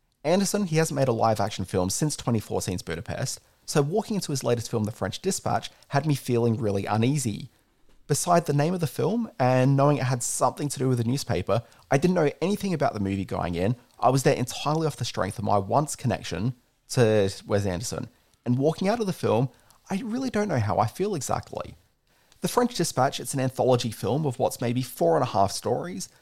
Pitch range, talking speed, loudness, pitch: 110-155 Hz, 215 wpm, -26 LUFS, 125 Hz